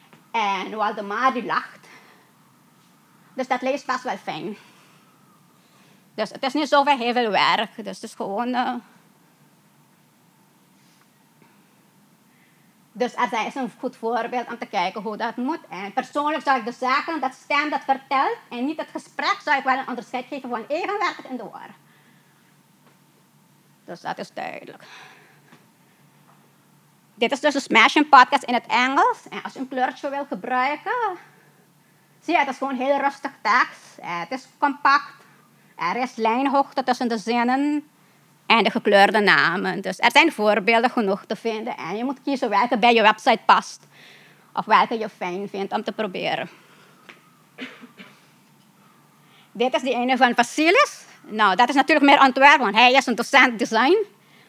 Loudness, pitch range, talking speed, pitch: -21 LUFS, 220-275 Hz, 155 wpm, 250 Hz